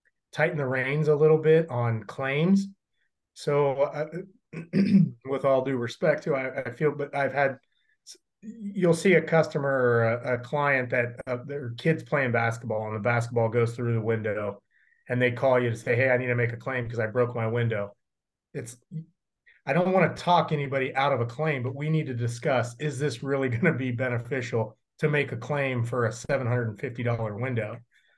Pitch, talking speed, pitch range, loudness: 135 Hz, 195 wpm, 120-155 Hz, -26 LUFS